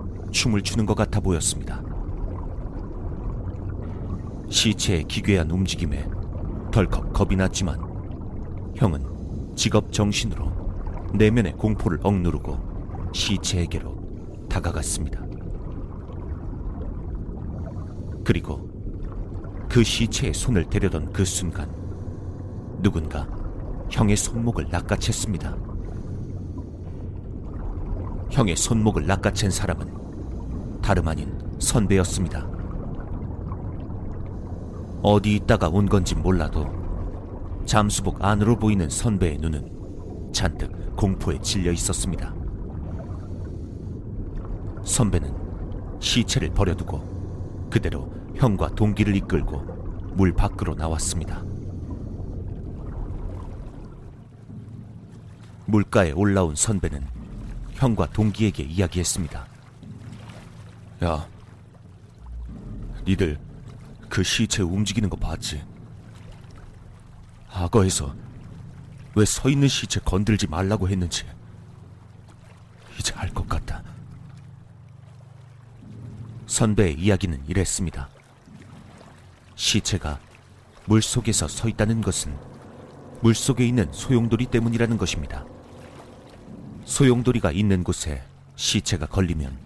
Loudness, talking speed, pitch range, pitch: -25 LUFS, 195 characters per minute, 90-110 Hz, 95 Hz